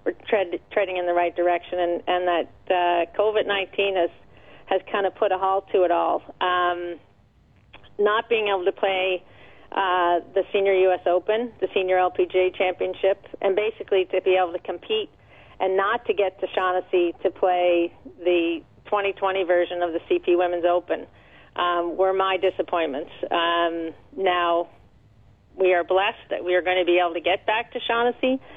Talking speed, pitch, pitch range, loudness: 170 wpm, 185 Hz, 175-195 Hz, -23 LUFS